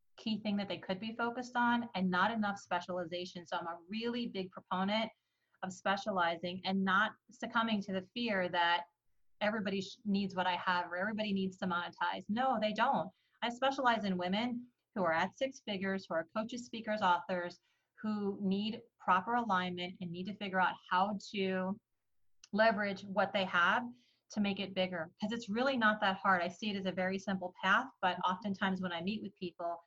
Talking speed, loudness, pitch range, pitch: 190 wpm, -35 LUFS, 180-220 Hz, 195 Hz